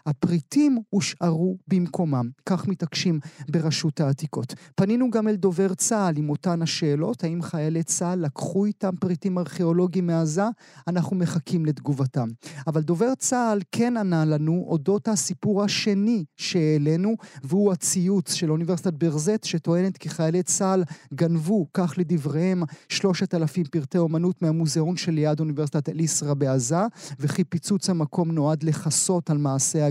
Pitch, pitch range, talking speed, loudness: 170 Hz, 155-190 Hz, 130 wpm, -24 LUFS